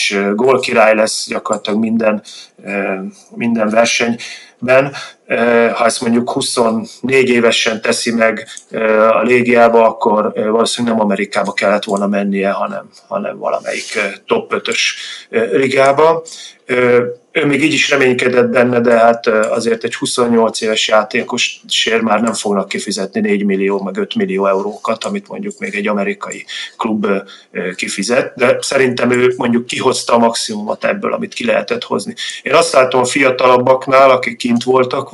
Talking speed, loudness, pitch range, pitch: 135 wpm, -14 LUFS, 115-130 Hz, 120 Hz